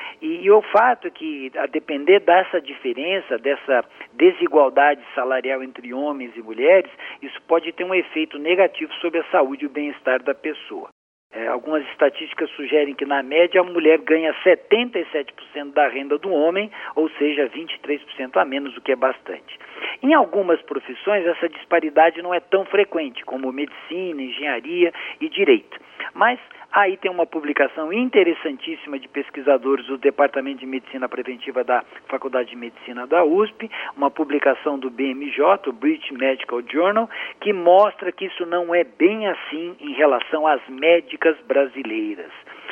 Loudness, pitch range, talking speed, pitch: -20 LUFS, 140-190 Hz, 150 wpm, 155 Hz